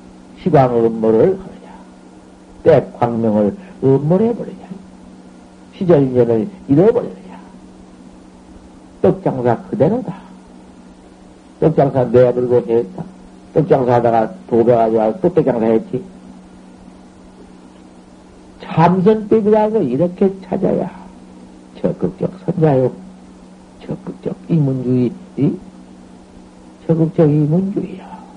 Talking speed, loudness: 205 characters per minute, -15 LUFS